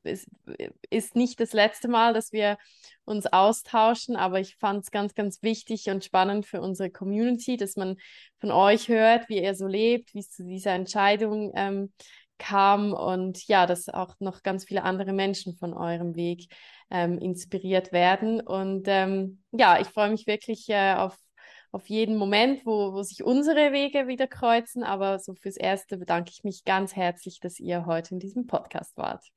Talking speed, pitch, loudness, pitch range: 180 wpm, 195 Hz, -26 LUFS, 190-220 Hz